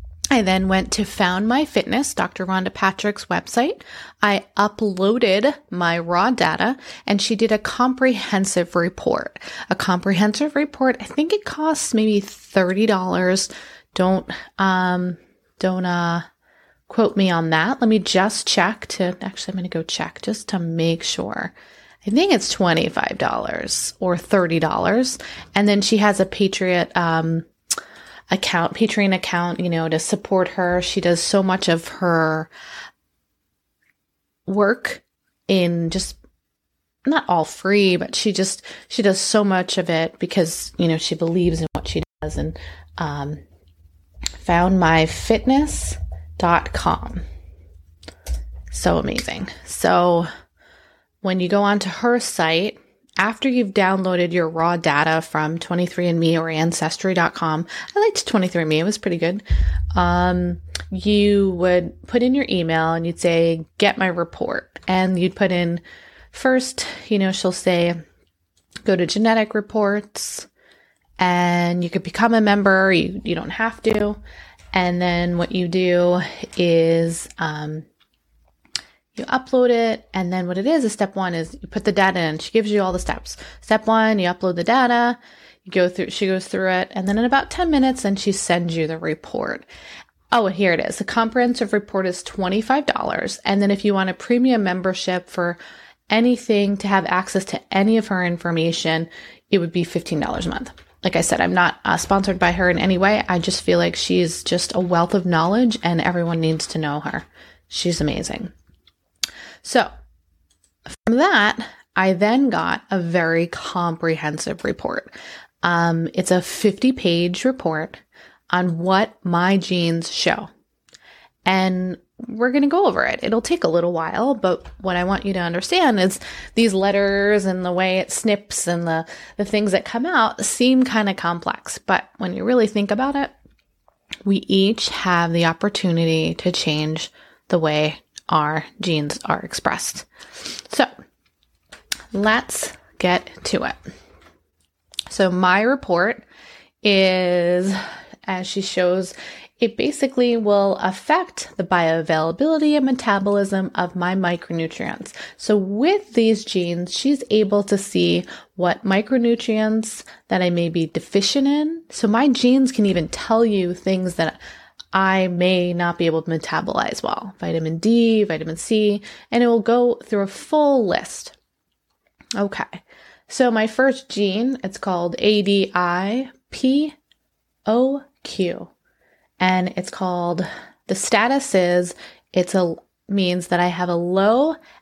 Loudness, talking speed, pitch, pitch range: -20 LUFS, 150 wpm, 185 Hz, 170-215 Hz